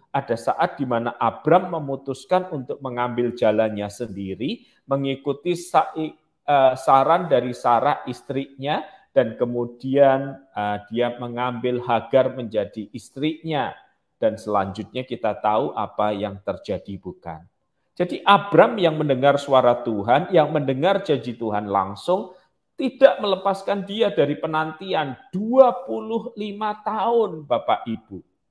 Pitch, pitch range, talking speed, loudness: 135 Hz, 120-175 Hz, 105 wpm, -22 LUFS